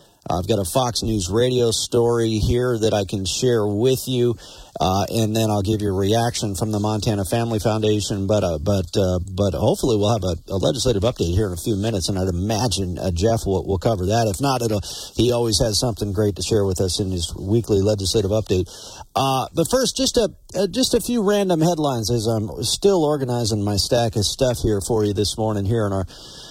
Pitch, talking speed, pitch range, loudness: 110 Hz, 220 wpm, 100-120 Hz, -20 LUFS